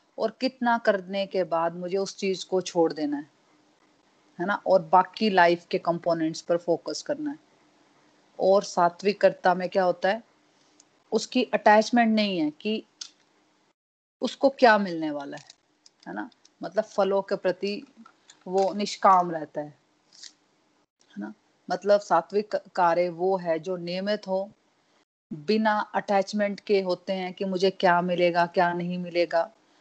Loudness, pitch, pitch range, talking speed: -25 LUFS, 190 Hz, 175-210 Hz, 145 wpm